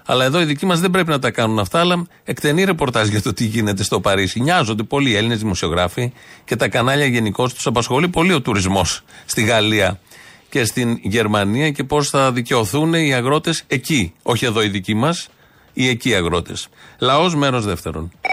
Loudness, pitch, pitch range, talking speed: -17 LUFS, 125 Hz, 110-150 Hz, 185 wpm